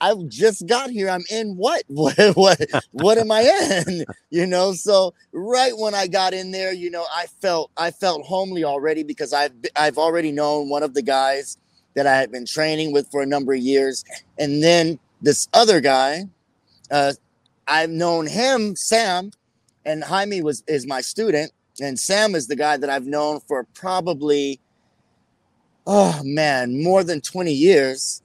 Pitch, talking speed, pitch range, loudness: 155 Hz, 175 wpm, 140-190 Hz, -19 LUFS